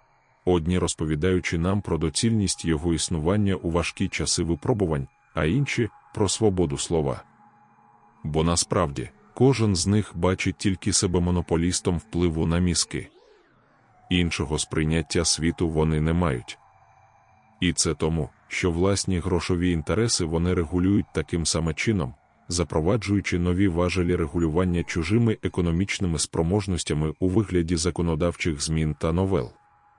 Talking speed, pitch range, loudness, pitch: 120 wpm, 85-95 Hz, -24 LUFS, 90 Hz